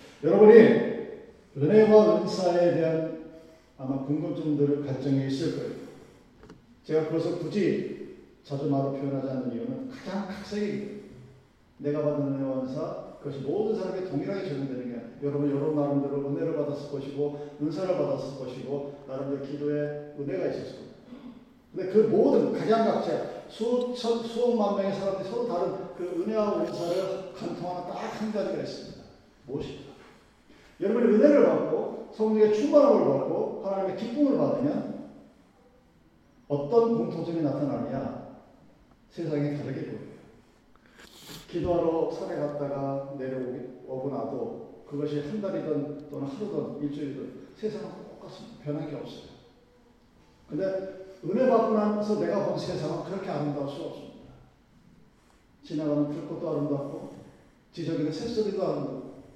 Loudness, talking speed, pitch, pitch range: -27 LUFS, 320 characters per minute, 160 Hz, 145-205 Hz